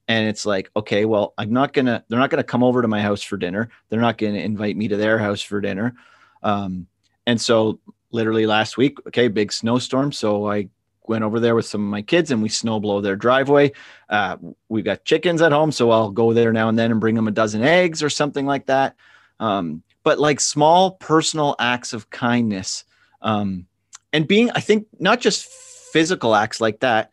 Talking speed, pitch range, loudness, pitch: 210 wpm, 105-145 Hz, -19 LUFS, 115 Hz